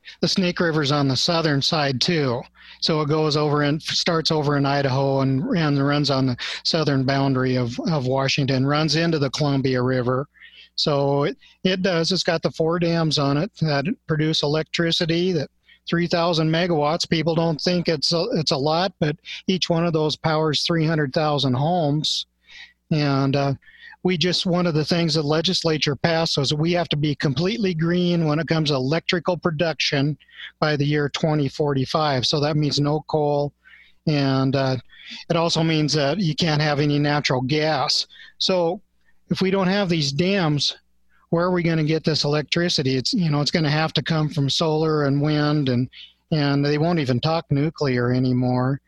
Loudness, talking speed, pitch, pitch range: -21 LUFS, 180 wpm, 155 Hz, 140-170 Hz